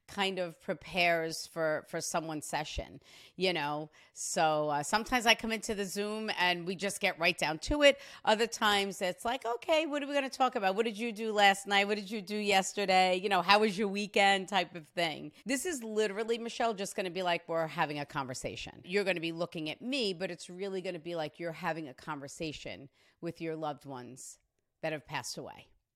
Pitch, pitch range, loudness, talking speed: 190 Hz, 165-215 Hz, -32 LUFS, 215 wpm